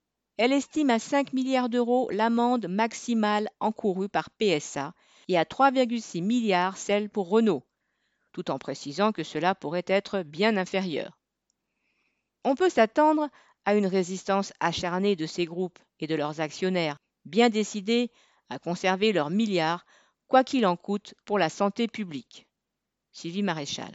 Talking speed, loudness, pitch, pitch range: 145 wpm, -27 LUFS, 205 Hz, 180-235 Hz